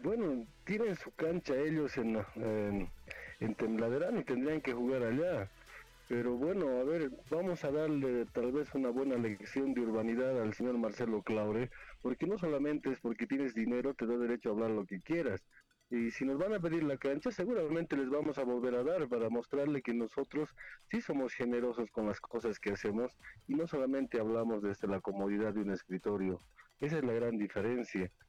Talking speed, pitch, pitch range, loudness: 190 wpm, 125 Hz, 110-145 Hz, -36 LUFS